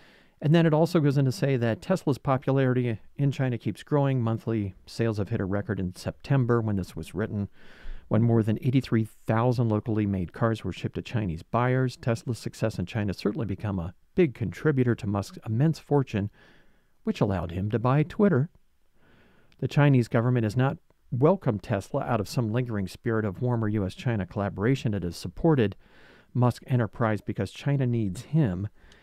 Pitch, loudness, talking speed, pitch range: 115 Hz, -27 LUFS, 175 wpm, 100-135 Hz